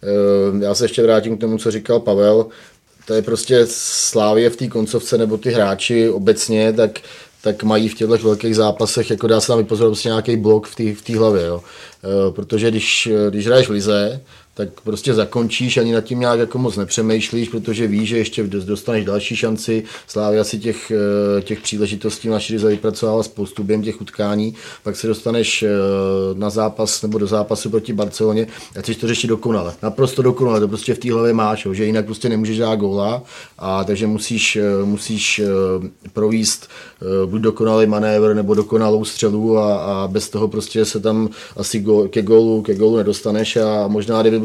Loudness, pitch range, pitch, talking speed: -17 LUFS, 105-115 Hz, 110 Hz, 180 wpm